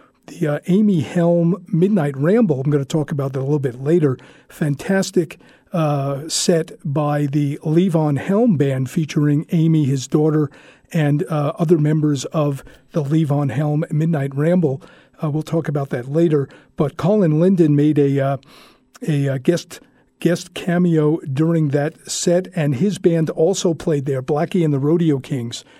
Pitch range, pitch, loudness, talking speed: 145-170 Hz, 155 Hz, -18 LUFS, 160 wpm